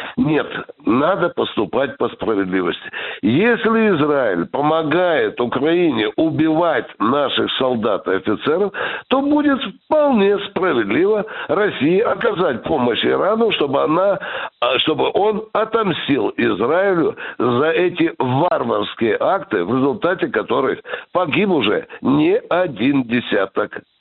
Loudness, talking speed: -18 LUFS, 100 wpm